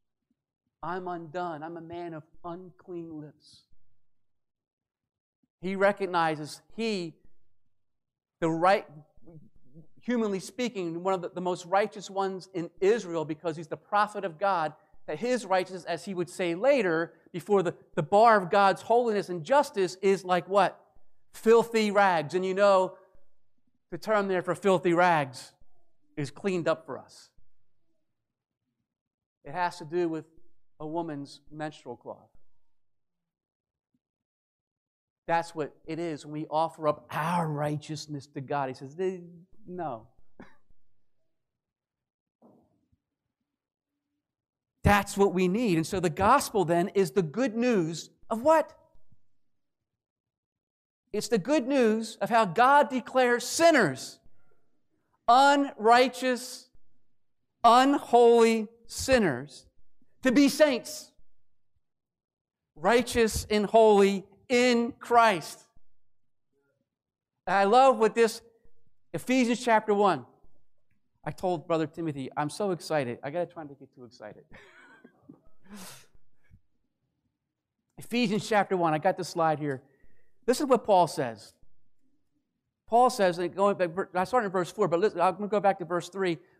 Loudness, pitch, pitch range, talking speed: -26 LUFS, 185 Hz, 160-220 Hz, 125 wpm